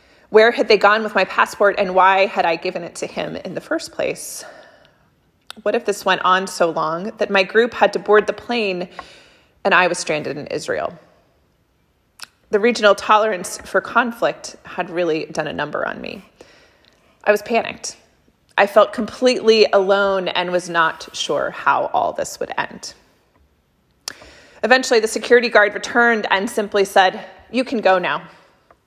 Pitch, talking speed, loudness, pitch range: 205 Hz, 165 wpm, -18 LUFS, 185-230 Hz